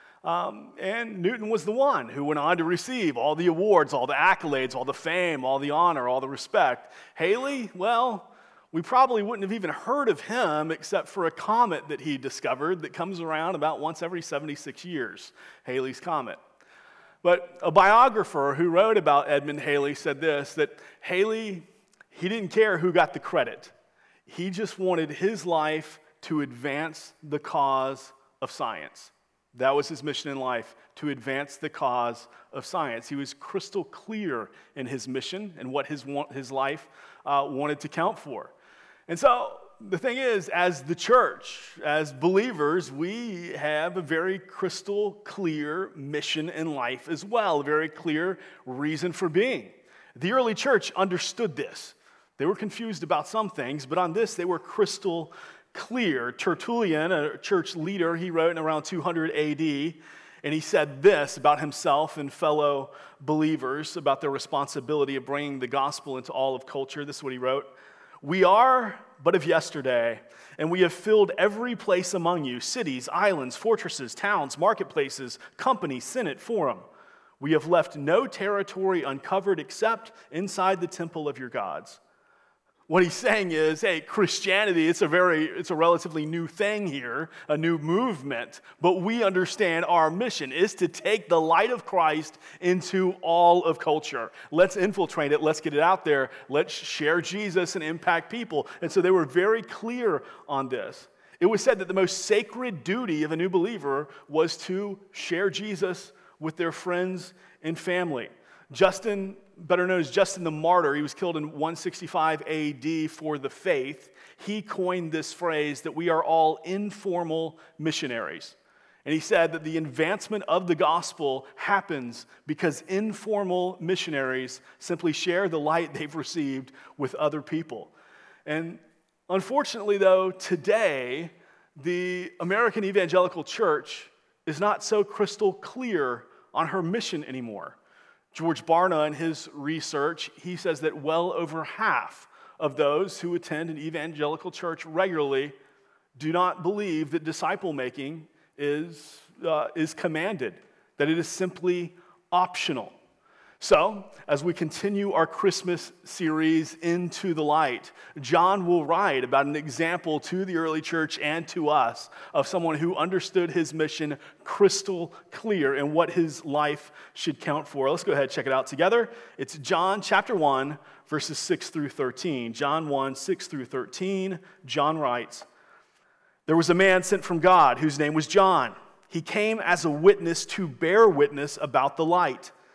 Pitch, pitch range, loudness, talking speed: 170 Hz, 150-190 Hz, -26 LUFS, 160 wpm